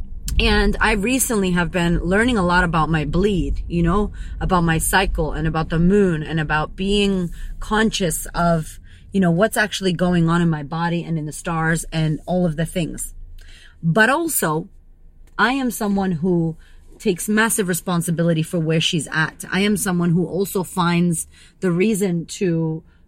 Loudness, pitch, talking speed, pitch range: -20 LUFS, 175 Hz, 170 wpm, 160-195 Hz